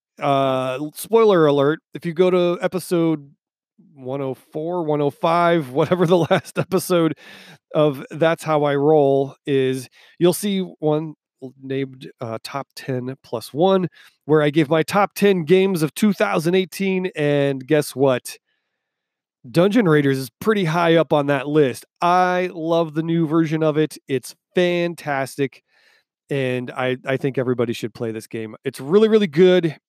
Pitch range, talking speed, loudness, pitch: 135-180 Hz, 145 wpm, -20 LUFS, 155 Hz